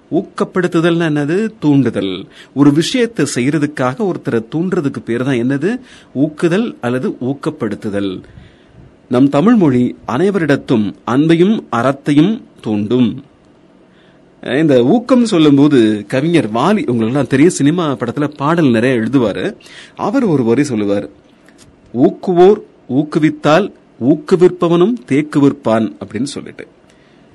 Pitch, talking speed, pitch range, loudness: 145 Hz, 90 wpm, 125-175 Hz, -14 LUFS